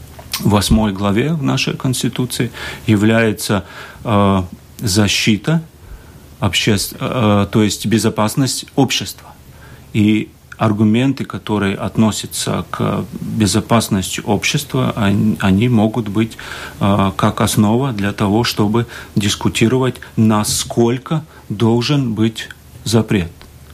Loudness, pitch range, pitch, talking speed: -16 LUFS, 100-120 Hz, 110 Hz, 95 wpm